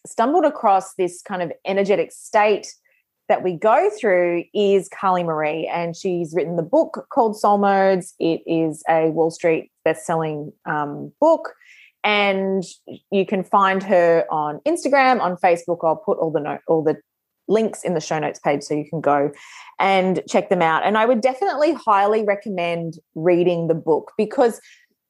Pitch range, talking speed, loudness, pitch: 165-210 Hz, 165 wpm, -20 LUFS, 185 Hz